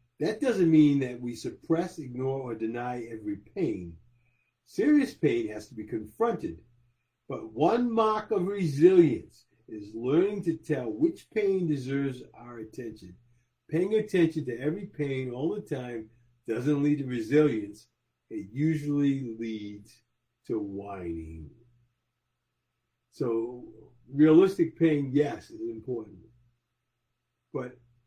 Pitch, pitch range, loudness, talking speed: 125 Hz, 120-155 Hz, -28 LUFS, 120 wpm